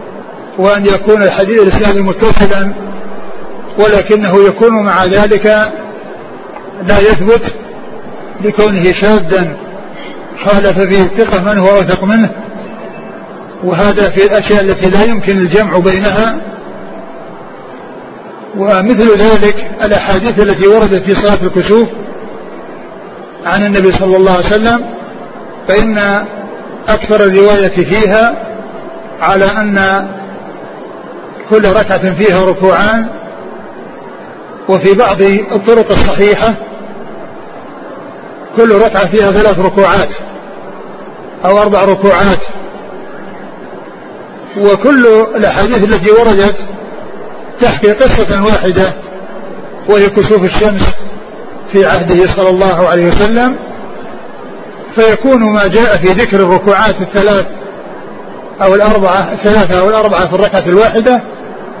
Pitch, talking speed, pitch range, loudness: 205 Hz, 90 wpm, 195-215 Hz, -8 LUFS